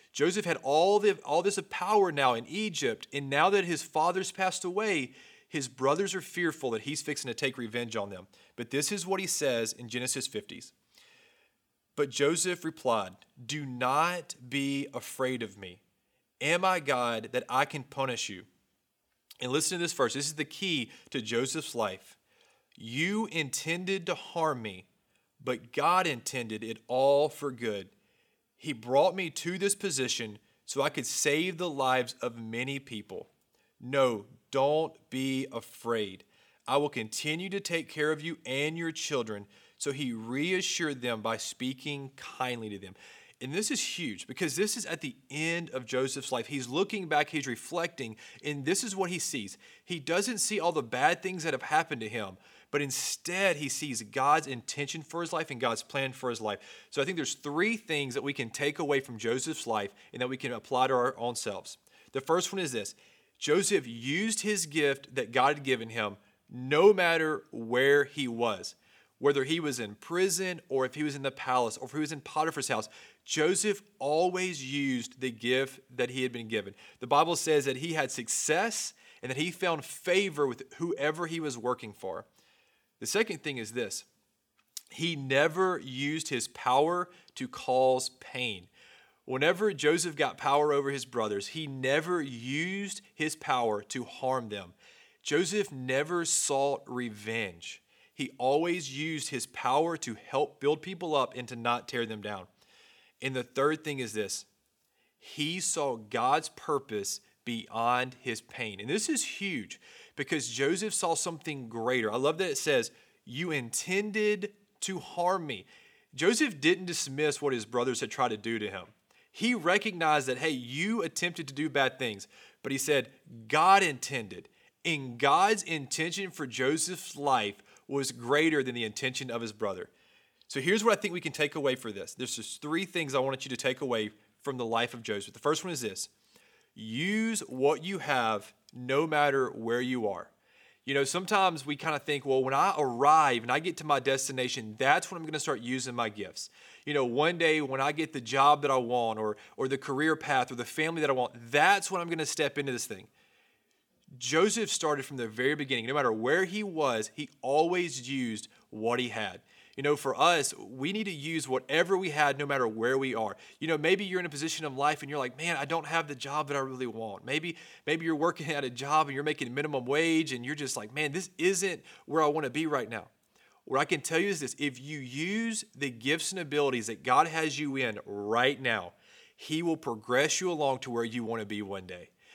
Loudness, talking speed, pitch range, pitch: -30 LUFS, 195 wpm, 125-165 Hz, 140 Hz